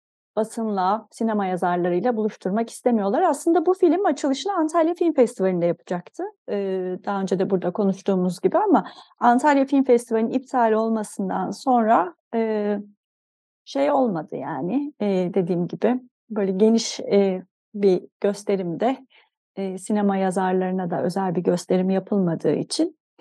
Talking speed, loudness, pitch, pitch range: 125 wpm, -22 LUFS, 210 Hz, 190-255 Hz